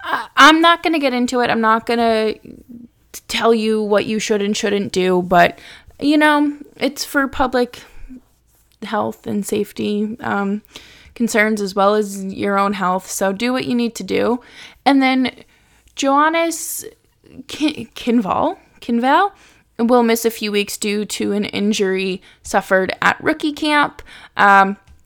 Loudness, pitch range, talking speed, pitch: -17 LUFS, 205-260 Hz, 150 wpm, 230 Hz